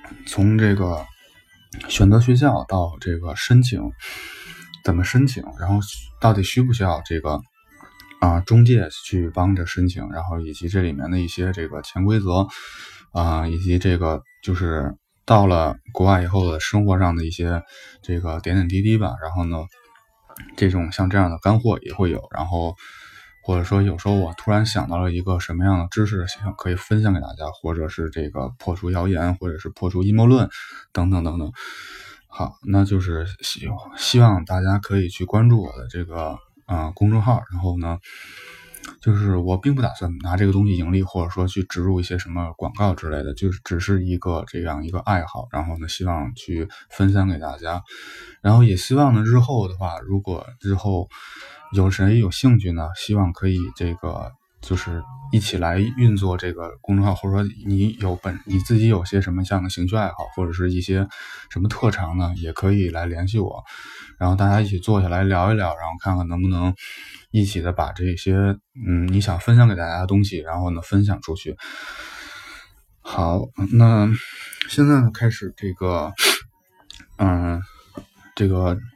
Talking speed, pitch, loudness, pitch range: 265 characters per minute, 95 Hz, -21 LUFS, 85-100 Hz